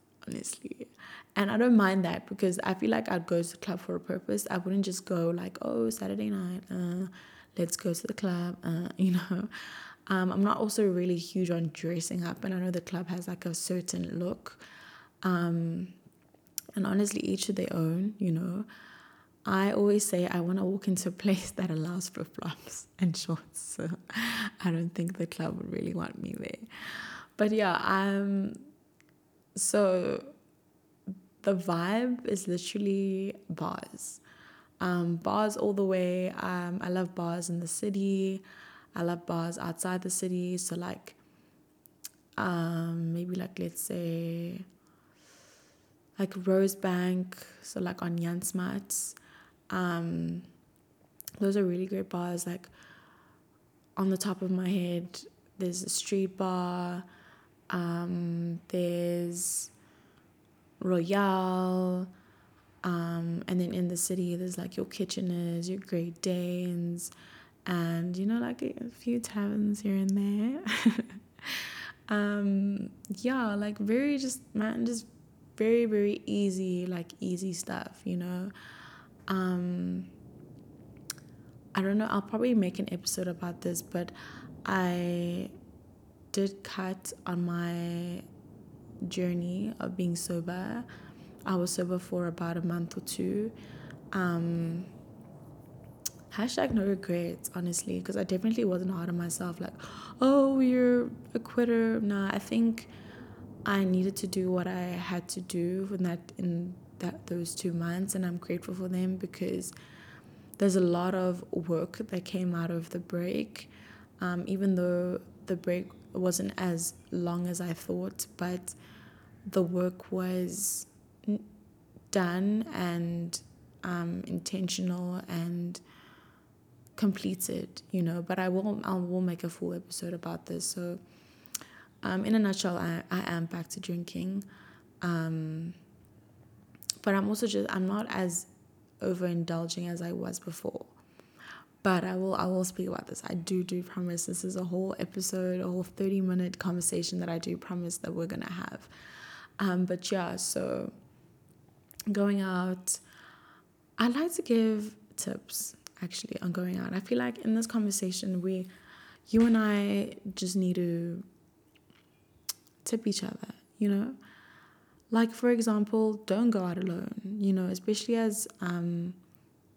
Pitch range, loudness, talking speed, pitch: 175-195 Hz, -32 LUFS, 145 wpm, 180 Hz